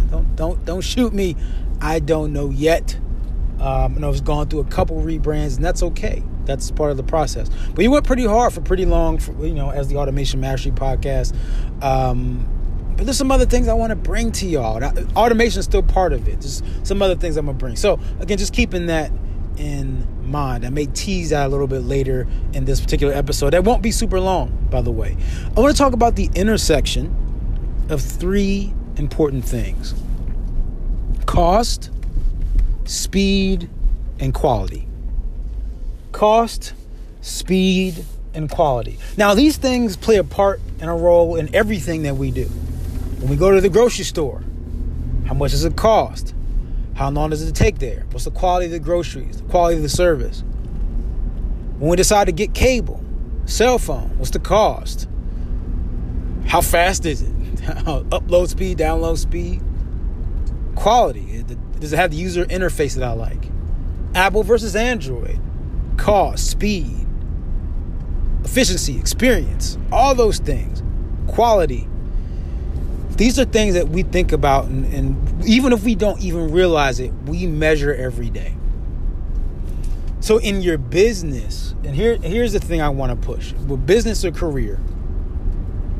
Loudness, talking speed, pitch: -20 LUFS, 165 wpm, 135 Hz